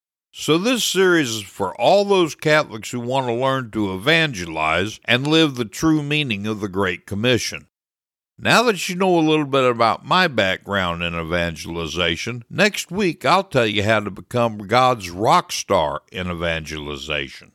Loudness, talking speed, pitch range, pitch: -19 LUFS, 165 wpm, 95-155 Hz, 120 Hz